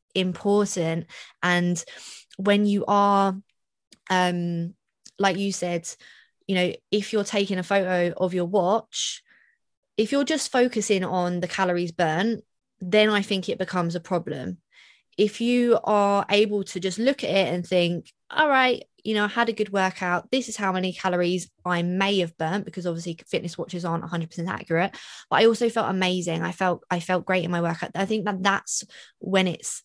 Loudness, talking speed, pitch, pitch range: -24 LUFS, 180 wpm, 190 Hz, 175-205 Hz